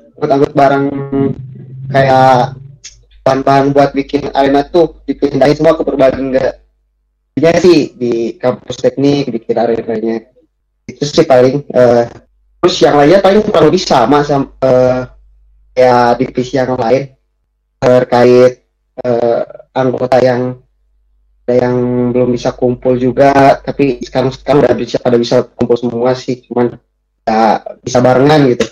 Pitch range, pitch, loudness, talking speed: 120-140 Hz, 125 Hz, -11 LUFS, 120 wpm